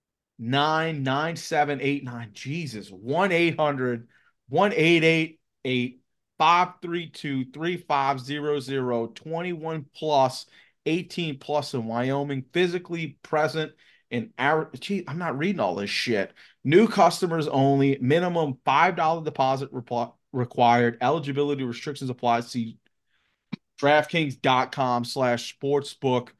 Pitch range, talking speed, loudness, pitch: 125-160 Hz, 105 wpm, -25 LUFS, 140 Hz